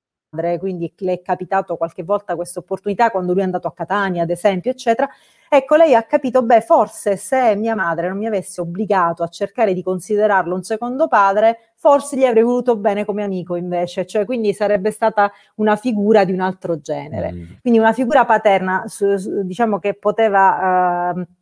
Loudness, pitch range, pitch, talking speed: -17 LUFS, 180-225 Hz, 200 Hz, 180 wpm